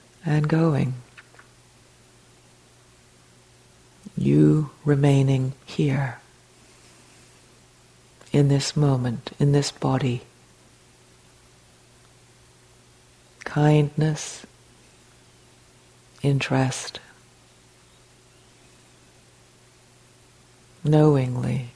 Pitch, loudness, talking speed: 130 Hz, -22 LUFS, 40 wpm